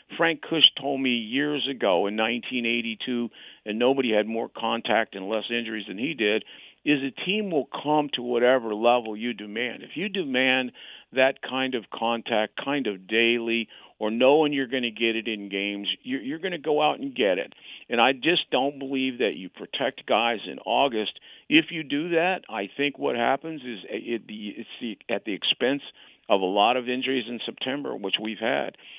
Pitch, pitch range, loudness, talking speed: 125 Hz, 115-140 Hz, -25 LUFS, 185 wpm